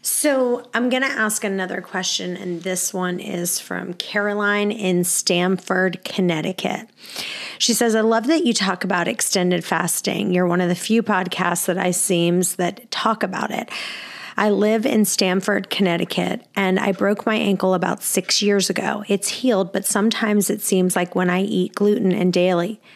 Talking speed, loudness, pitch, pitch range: 175 wpm, -20 LUFS, 195 Hz, 180-210 Hz